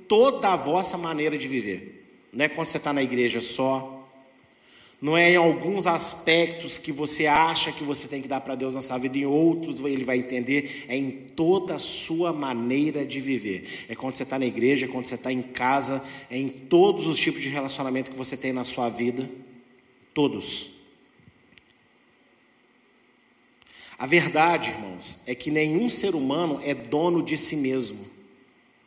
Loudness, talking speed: -24 LUFS, 175 wpm